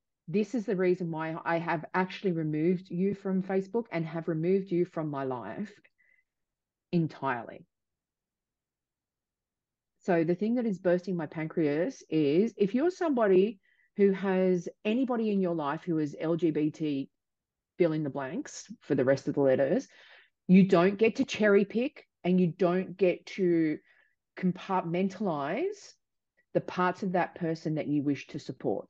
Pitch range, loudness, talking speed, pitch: 165-200 Hz, -29 LUFS, 150 wpm, 180 Hz